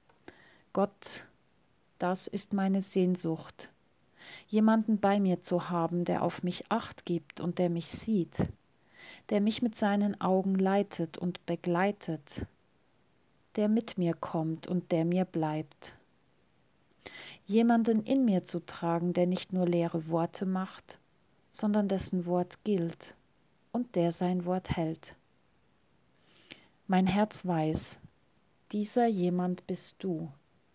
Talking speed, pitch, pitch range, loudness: 120 wpm, 180 Hz, 170-200 Hz, -31 LUFS